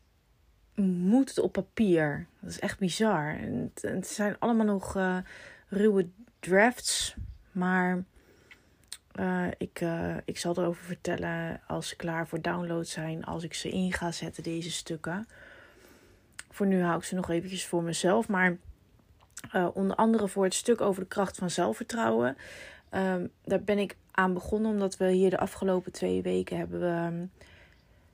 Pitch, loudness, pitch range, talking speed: 185 Hz, -30 LUFS, 170-195 Hz, 160 wpm